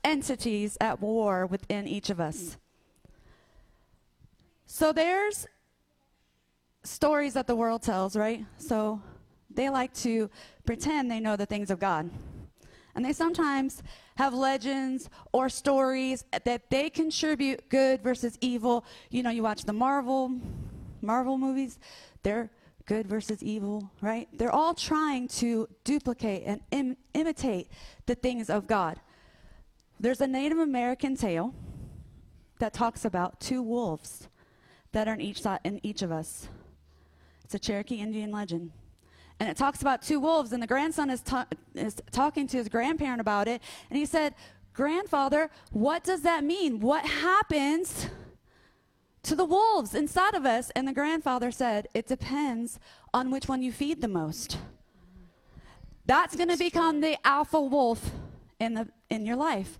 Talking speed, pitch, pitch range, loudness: 145 wpm, 250 Hz, 215-285 Hz, -29 LUFS